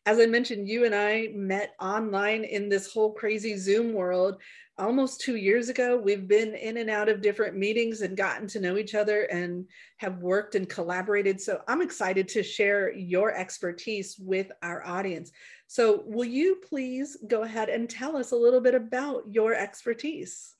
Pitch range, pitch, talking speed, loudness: 195-235 Hz, 215 Hz, 180 wpm, -27 LUFS